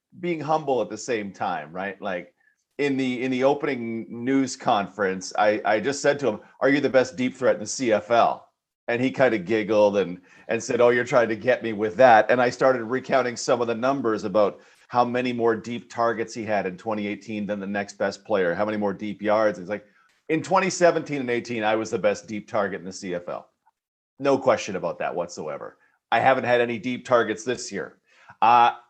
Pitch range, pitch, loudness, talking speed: 105-130 Hz, 120 Hz, -24 LUFS, 215 wpm